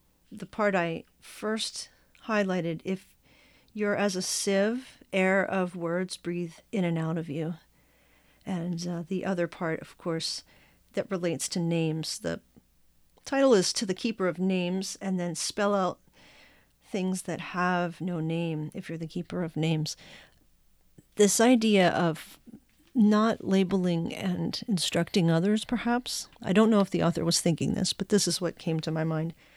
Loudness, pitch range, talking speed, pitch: -28 LUFS, 165-195 Hz, 160 wpm, 180 Hz